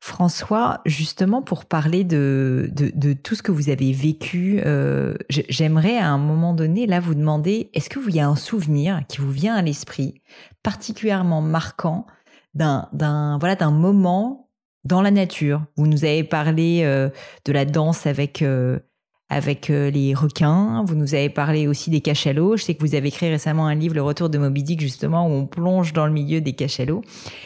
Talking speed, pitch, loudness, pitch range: 190 wpm, 155 Hz, -20 LUFS, 145-175 Hz